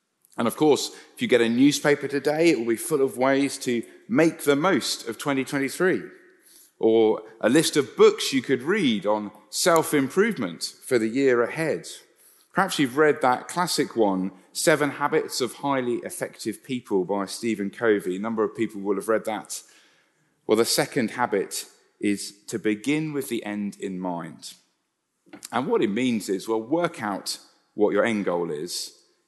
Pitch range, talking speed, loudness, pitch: 110-160 Hz, 170 wpm, -24 LUFS, 135 Hz